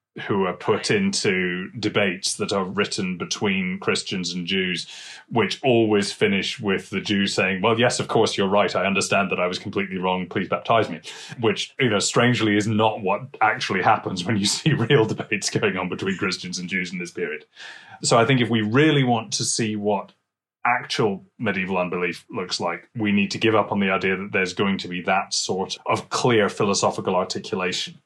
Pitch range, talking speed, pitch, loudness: 95-125 Hz, 195 wpm, 105 Hz, -22 LUFS